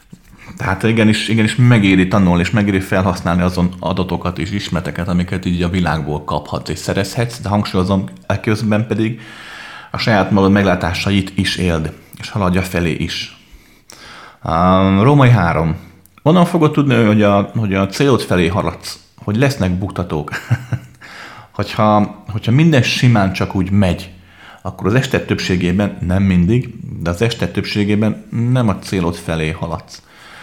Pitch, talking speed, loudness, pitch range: 95 Hz, 140 wpm, -15 LUFS, 90-110 Hz